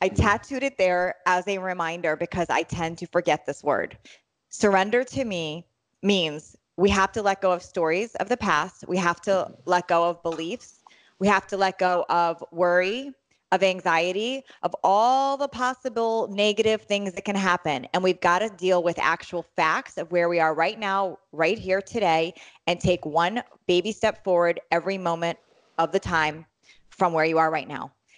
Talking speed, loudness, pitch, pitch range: 185 wpm, -24 LUFS, 180 Hz, 170-200 Hz